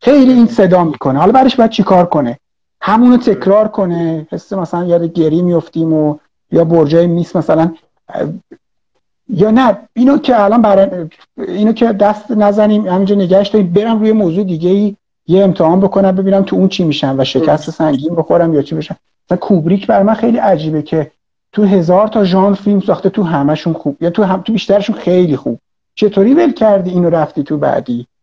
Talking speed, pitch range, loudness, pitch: 180 wpm, 165-210 Hz, -11 LUFS, 190 Hz